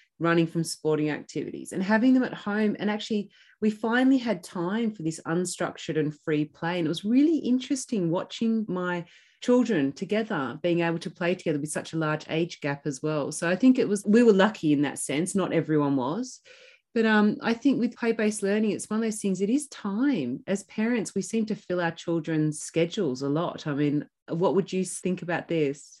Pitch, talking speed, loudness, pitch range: 185 Hz, 210 wpm, -26 LUFS, 165-220 Hz